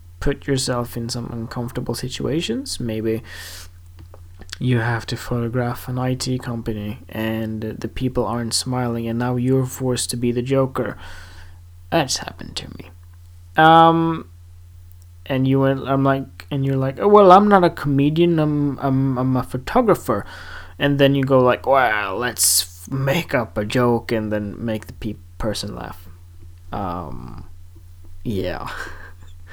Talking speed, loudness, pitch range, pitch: 140 wpm, -20 LUFS, 85-130 Hz, 115 Hz